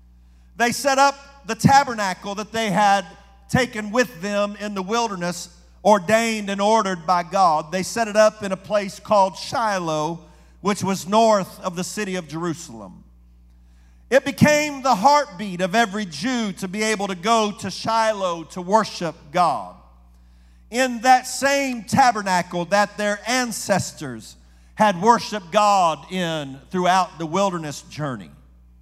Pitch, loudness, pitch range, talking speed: 200 Hz, -21 LUFS, 170-220 Hz, 140 wpm